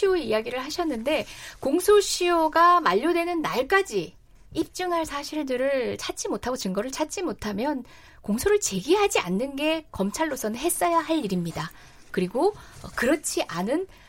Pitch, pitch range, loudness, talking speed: 315 Hz, 250-350 Hz, -25 LUFS, 315 characters per minute